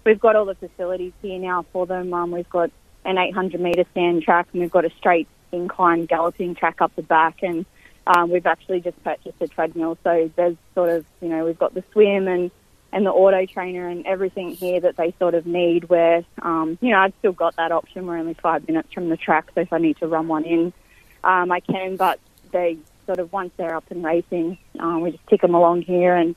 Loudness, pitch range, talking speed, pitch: -21 LUFS, 165-185 Hz, 235 wpm, 175 Hz